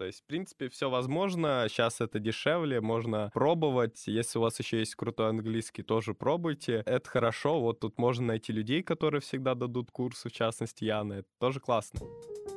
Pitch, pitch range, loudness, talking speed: 120 Hz, 110-135 Hz, -32 LUFS, 175 wpm